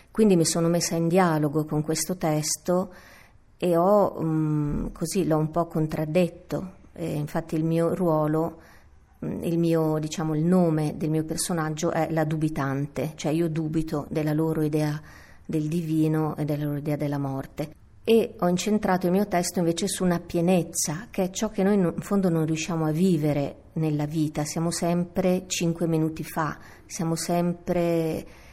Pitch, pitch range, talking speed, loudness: 160 Hz, 155-175 Hz, 160 wpm, -25 LUFS